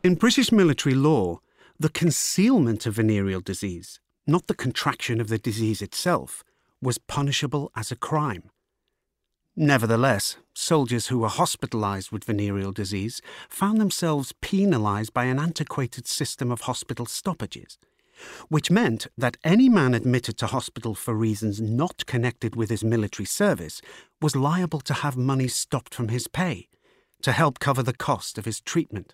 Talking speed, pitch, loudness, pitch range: 150 wpm, 125 Hz, -24 LUFS, 110-155 Hz